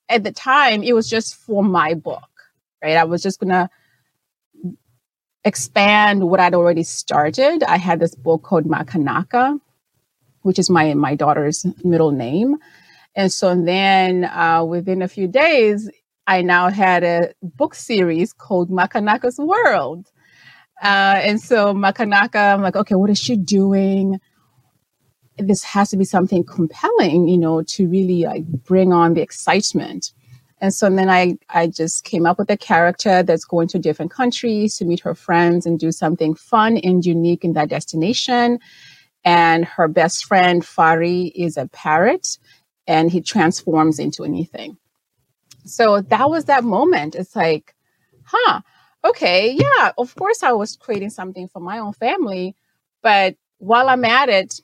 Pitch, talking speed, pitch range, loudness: 185 Hz, 155 wpm, 165-205 Hz, -17 LUFS